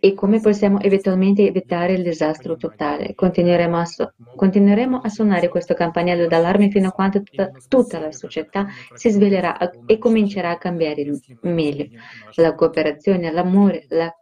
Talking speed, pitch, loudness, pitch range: 150 wpm, 180 Hz, -18 LUFS, 165-200 Hz